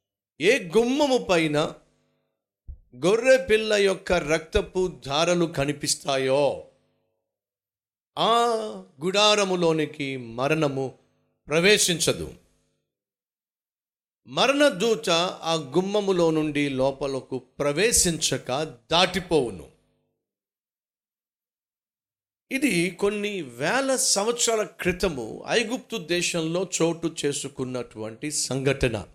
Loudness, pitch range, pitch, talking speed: -23 LUFS, 135-200 Hz, 165 Hz, 60 wpm